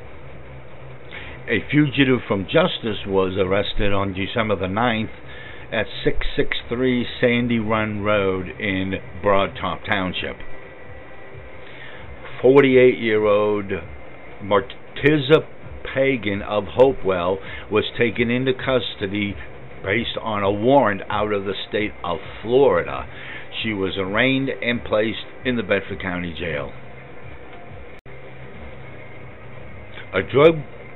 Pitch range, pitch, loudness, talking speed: 95-125 Hz, 105 Hz, -21 LUFS, 95 wpm